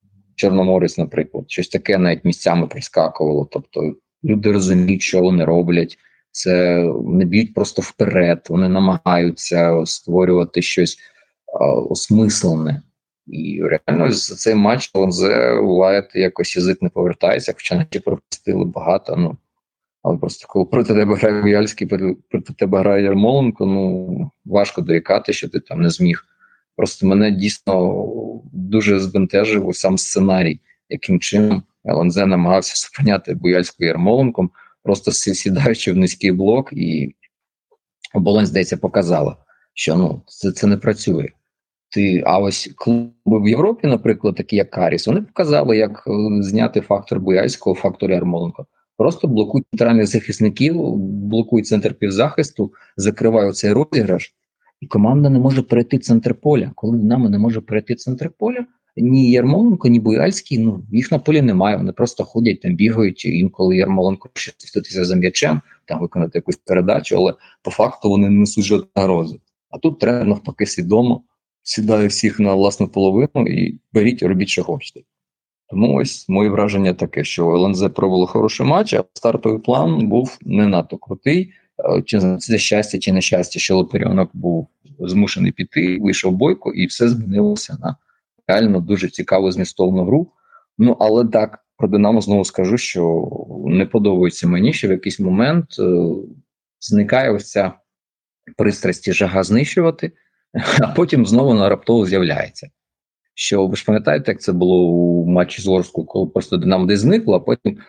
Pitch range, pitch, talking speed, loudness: 95-115 Hz, 100 Hz, 145 wpm, -17 LUFS